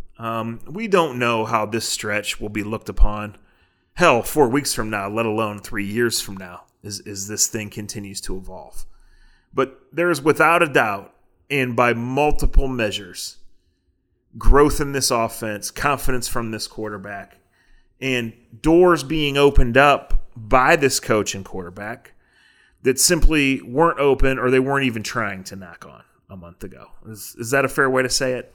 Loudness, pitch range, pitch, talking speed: -20 LUFS, 105-135 Hz, 115 Hz, 170 wpm